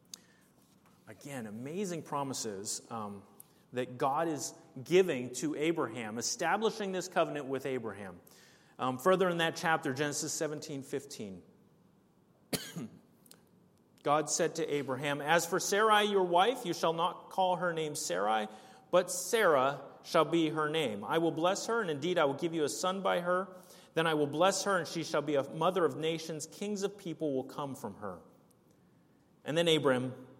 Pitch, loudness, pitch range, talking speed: 160 Hz, -32 LUFS, 145-180 Hz, 160 wpm